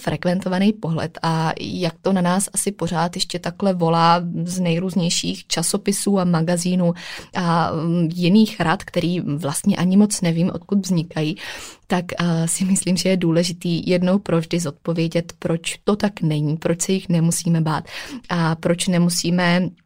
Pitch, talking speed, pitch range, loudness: 175 Hz, 150 wpm, 165-185 Hz, -20 LUFS